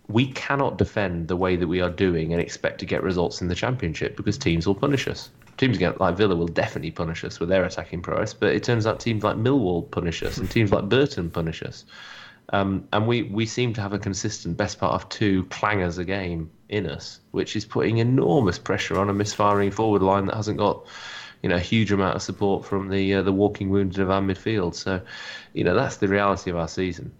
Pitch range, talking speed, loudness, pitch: 90-105 Hz, 230 wpm, -24 LUFS, 100 Hz